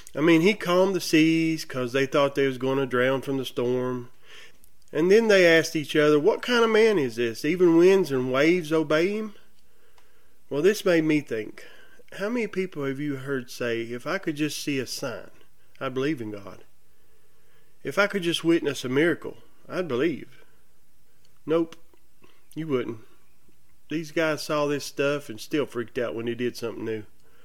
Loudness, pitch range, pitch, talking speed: -24 LUFS, 130-170 Hz, 150 Hz, 185 wpm